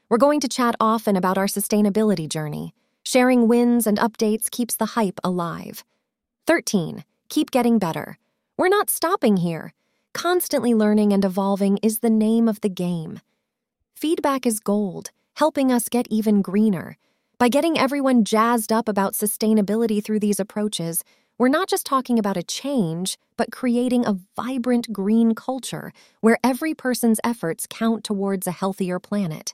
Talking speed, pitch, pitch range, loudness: 150 wpm, 220 Hz, 200-245 Hz, -21 LUFS